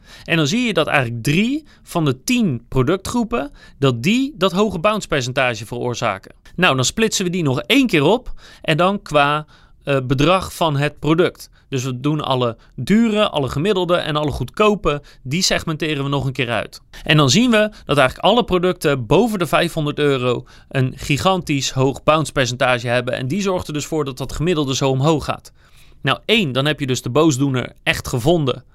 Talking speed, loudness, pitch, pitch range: 190 wpm, -18 LUFS, 150 Hz, 135-180 Hz